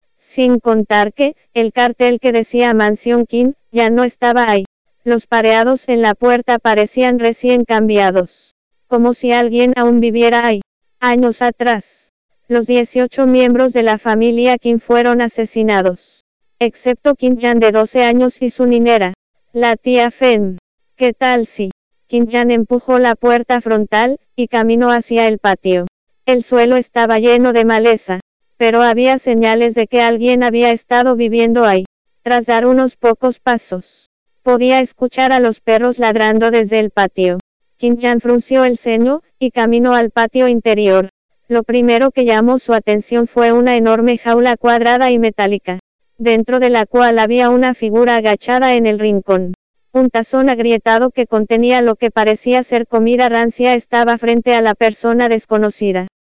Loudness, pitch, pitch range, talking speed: -13 LUFS, 235 Hz, 225-245 Hz, 155 wpm